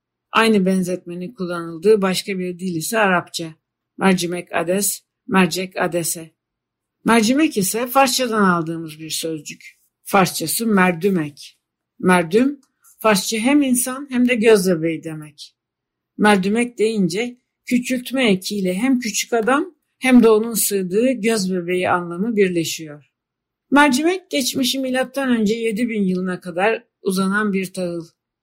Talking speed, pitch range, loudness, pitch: 115 wpm, 175-235 Hz, -18 LUFS, 200 Hz